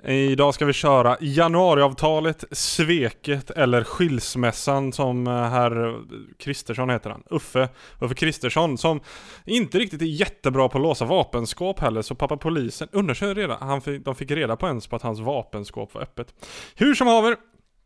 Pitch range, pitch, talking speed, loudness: 125-160 Hz, 140 Hz, 150 wpm, -22 LUFS